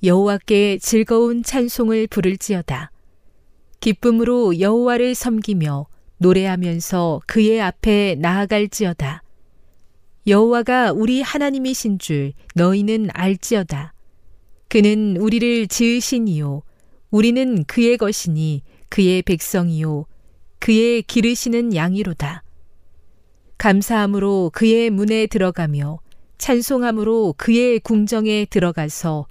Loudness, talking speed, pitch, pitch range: -18 LUFS, 250 characters per minute, 200 Hz, 155-225 Hz